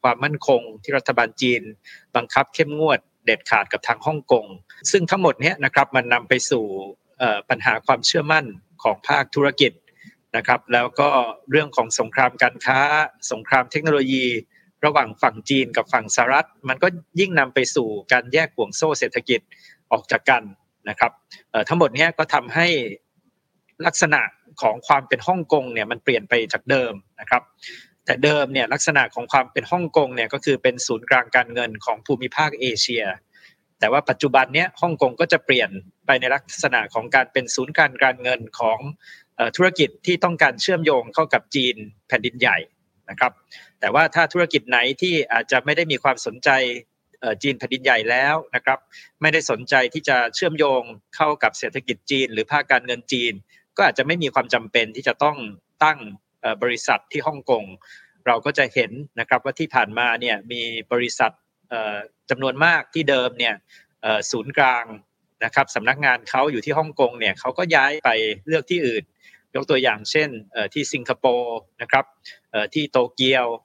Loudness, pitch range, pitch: -20 LUFS, 120-155 Hz, 135 Hz